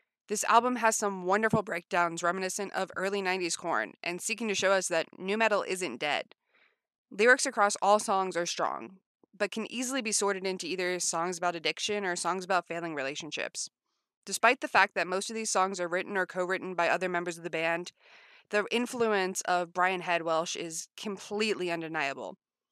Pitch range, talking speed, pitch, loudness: 175-210 Hz, 180 wpm, 190 Hz, -30 LUFS